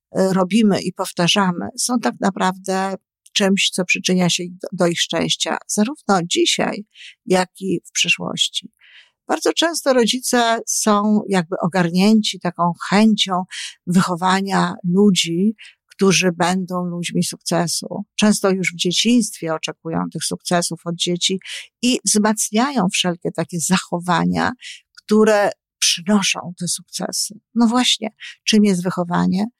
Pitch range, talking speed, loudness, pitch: 175-210 Hz, 115 wpm, -18 LUFS, 190 Hz